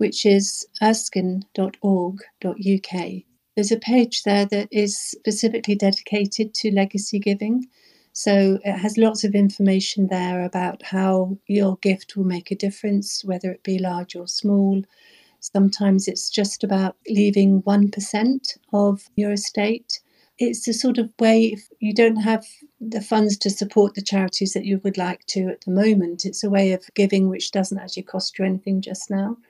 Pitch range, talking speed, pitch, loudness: 190-215 Hz, 165 wpm, 200 Hz, -21 LUFS